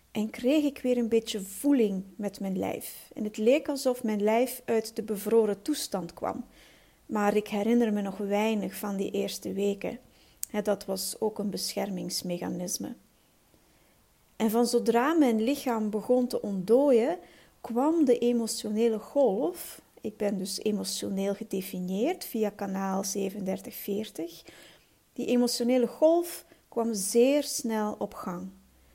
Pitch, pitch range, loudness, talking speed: 220 Hz, 200-240 Hz, -29 LUFS, 135 wpm